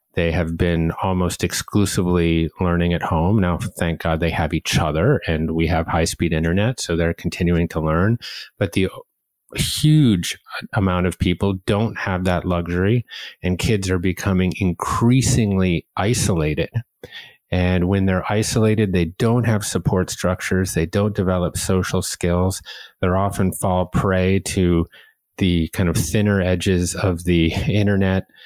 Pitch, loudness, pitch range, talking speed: 90 Hz, -20 LUFS, 85-100 Hz, 145 wpm